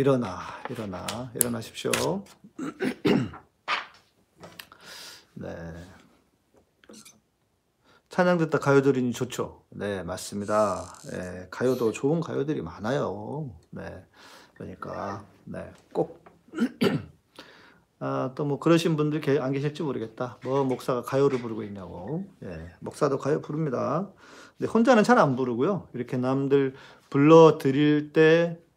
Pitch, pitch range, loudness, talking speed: 130 Hz, 110-150 Hz, -26 LUFS, 230 characters per minute